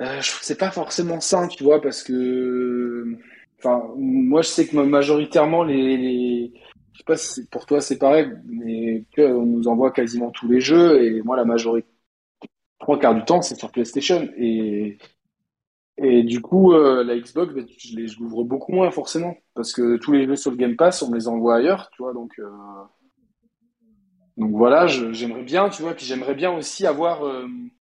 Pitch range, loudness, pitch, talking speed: 120-170 Hz, -20 LUFS, 135 Hz, 195 wpm